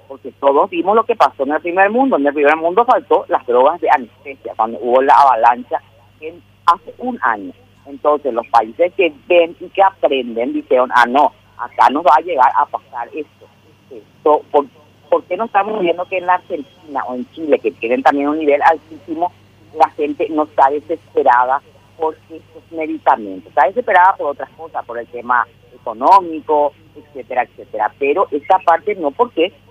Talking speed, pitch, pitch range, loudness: 180 wpm, 160 Hz, 135-195 Hz, -15 LUFS